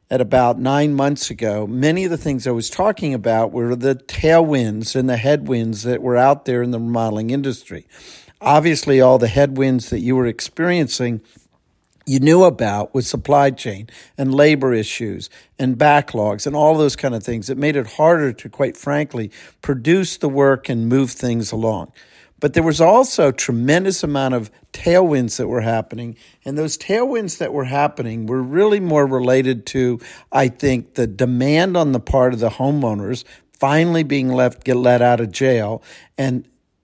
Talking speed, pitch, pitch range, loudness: 175 wpm, 130 Hz, 120-145 Hz, -17 LUFS